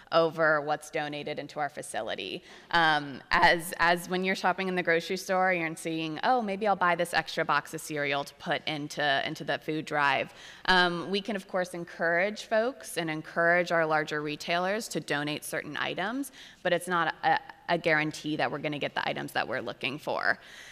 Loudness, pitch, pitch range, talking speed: -29 LUFS, 165 Hz, 155-185 Hz, 190 wpm